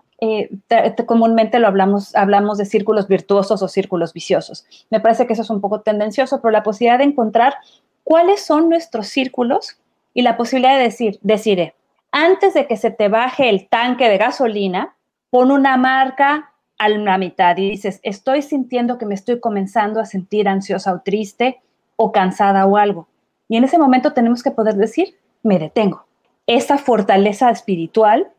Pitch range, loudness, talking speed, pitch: 200-255 Hz, -16 LUFS, 175 wpm, 225 Hz